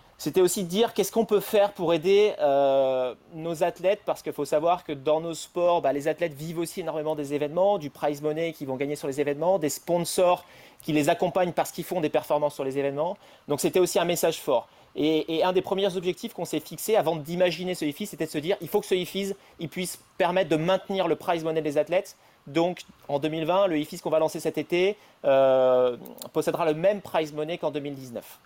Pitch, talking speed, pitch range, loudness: 165 Hz, 225 wpm, 150-185 Hz, -26 LUFS